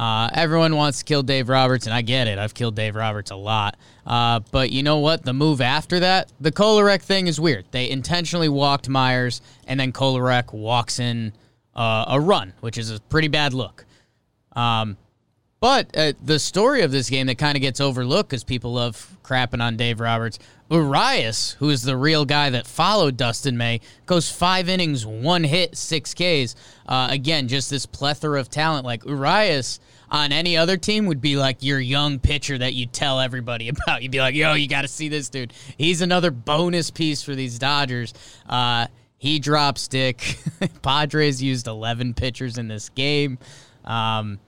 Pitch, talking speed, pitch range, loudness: 135 Hz, 190 wpm, 120-150 Hz, -21 LUFS